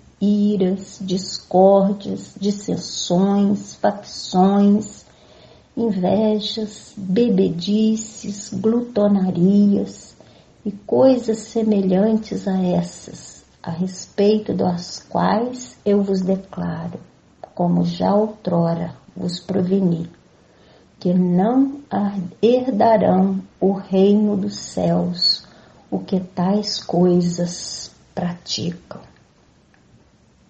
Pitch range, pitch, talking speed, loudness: 180-210 Hz, 195 Hz, 70 wpm, -19 LUFS